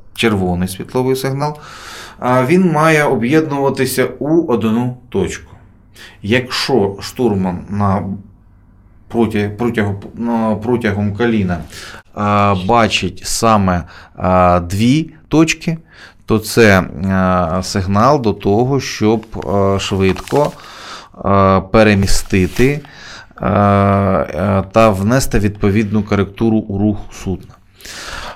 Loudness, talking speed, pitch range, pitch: -15 LUFS, 70 wpm, 95-120 Hz, 105 Hz